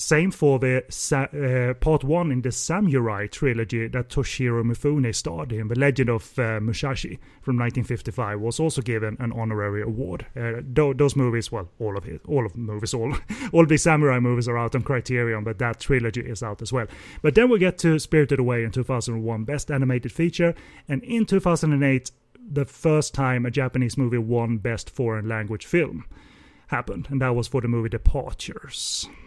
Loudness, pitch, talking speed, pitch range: -24 LUFS, 125 Hz, 185 wpm, 115-145 Hz